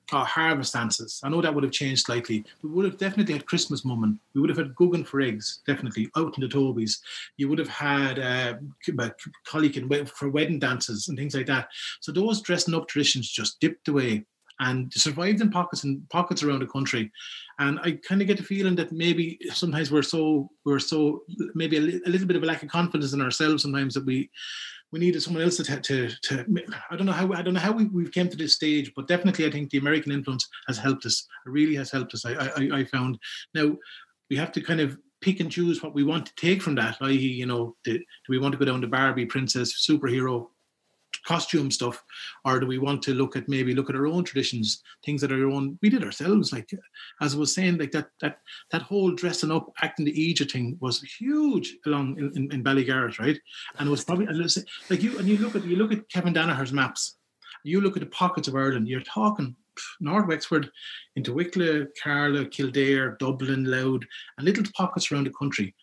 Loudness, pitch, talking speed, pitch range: -26 LUFS, 145 Hz, 225 wpm, 135-170 Hz